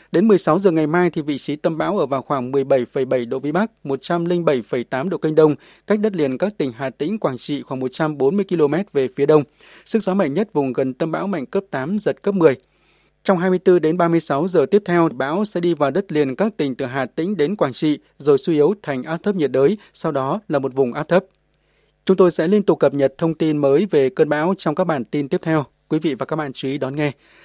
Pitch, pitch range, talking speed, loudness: 155 Hz, 140-185 Hz, 250 wpm, -19 LUFS